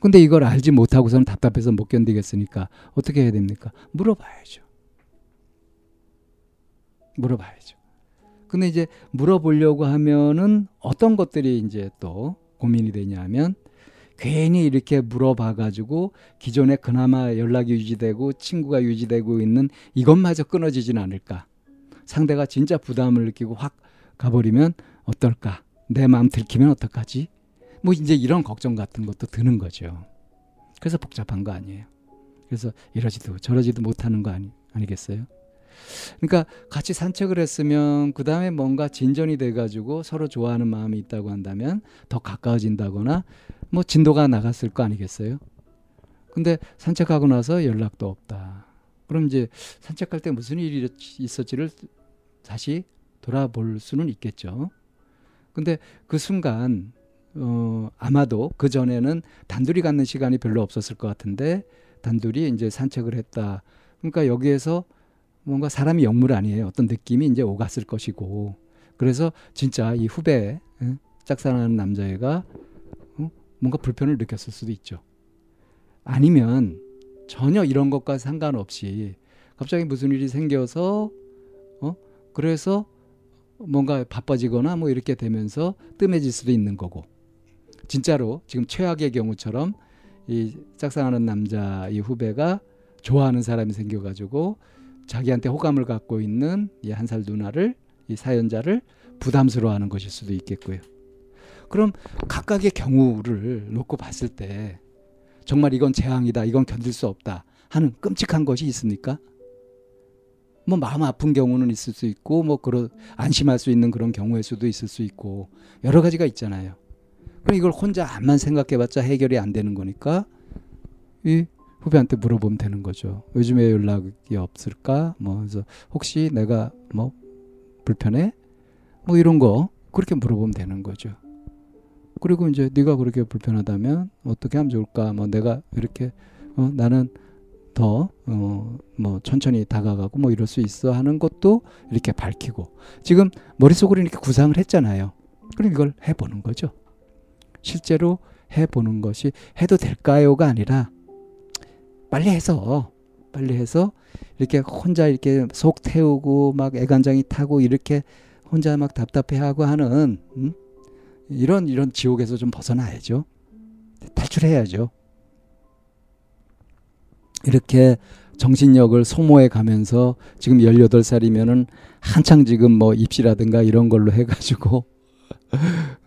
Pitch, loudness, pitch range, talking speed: 125 Hz, -21 LUFS, 110-145 Hz, 295 characters per minute